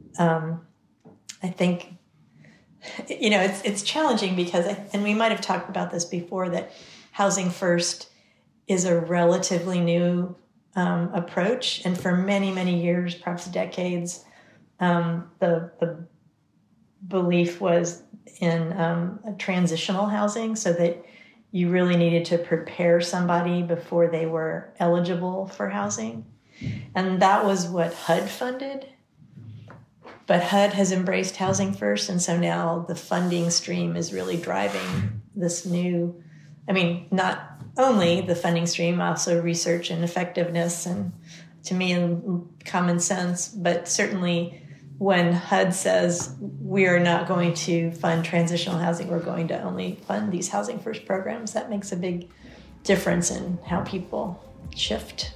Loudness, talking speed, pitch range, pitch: -25 LUFS, 140 wpm, 170-190 Hz, 175 Hz